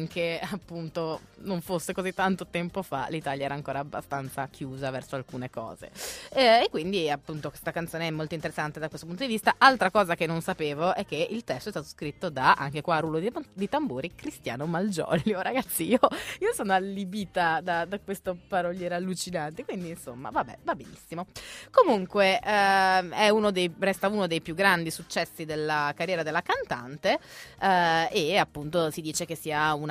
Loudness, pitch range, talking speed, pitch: -27 LUFS, 155-195 Hz, 180 wpm, 170 Hz